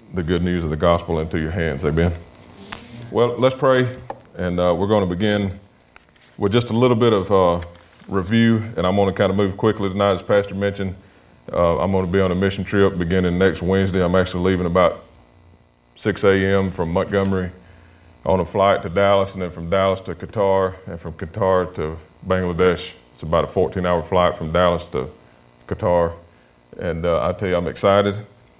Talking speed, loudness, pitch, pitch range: 195 wpm, -19 LUFS, 90 Hz, 85-100 Hz